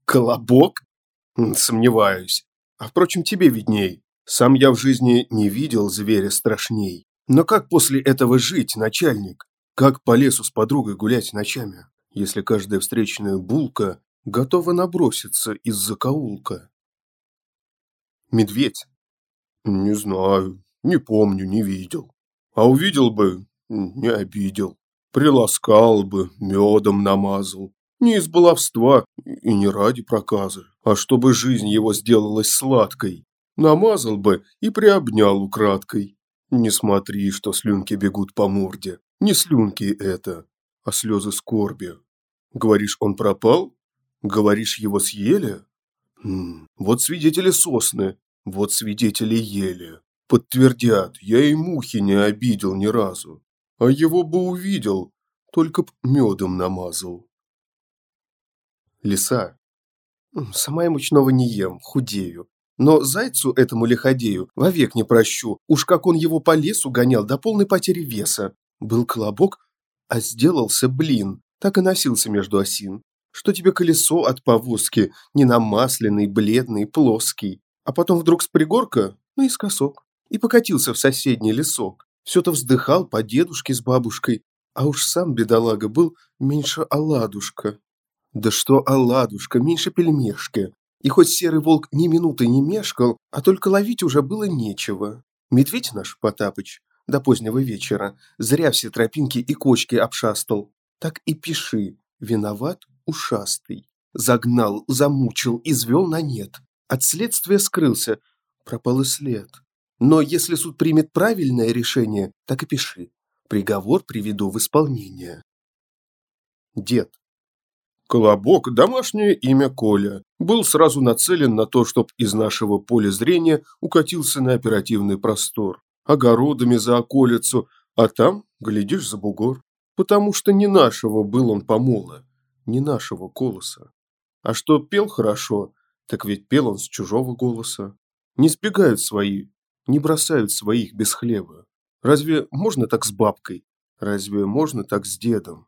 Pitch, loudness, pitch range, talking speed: 120 Hz, -19 LUFS, 105-150 Hz, 125 wpm